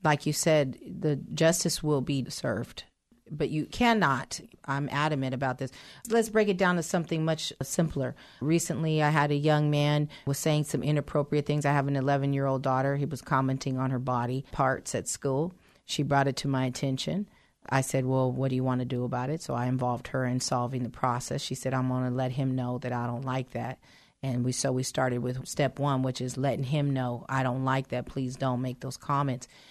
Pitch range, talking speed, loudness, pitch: 130-150 Hz, 220 wpm, -29 LUFS, 135 Hz